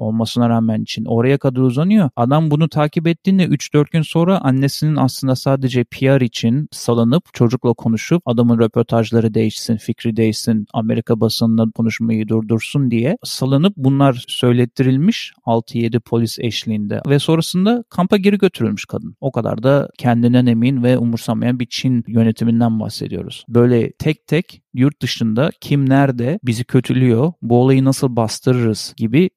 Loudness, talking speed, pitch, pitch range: -16 LUFS, 140 wpm, 125 Hz, 115-140 Hz